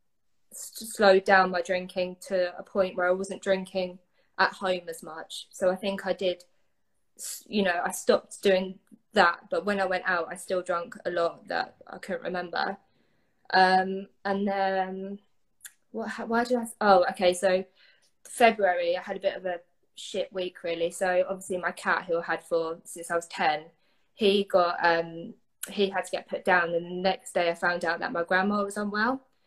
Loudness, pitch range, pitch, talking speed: -27 LUFS, 175-200 Hz, 185 Hz, 190 wpm